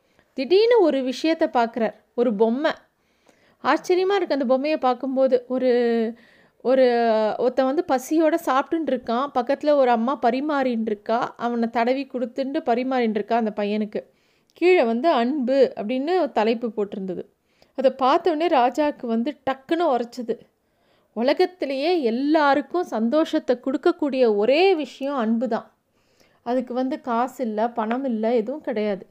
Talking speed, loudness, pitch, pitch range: 120 wpm, -22 LUFS, 255 Hz, 235-295 Hz